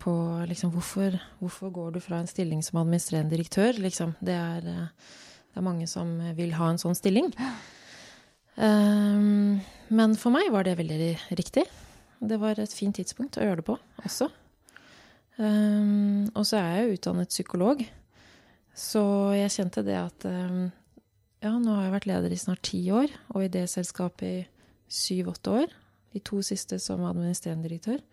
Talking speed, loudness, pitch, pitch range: 170 wpm, -28 LUFS, 185 Hz, 170-210 Hz